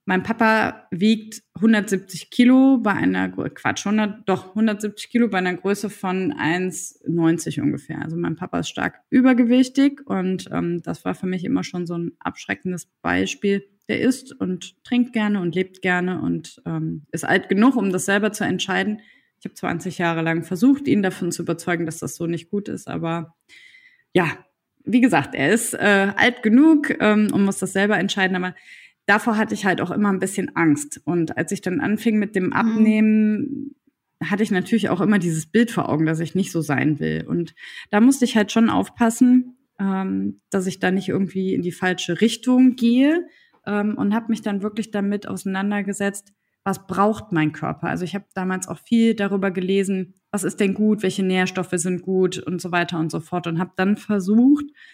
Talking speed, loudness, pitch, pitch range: 190 wpm, -21 LUFS, 195 Hz, 180-220 Hz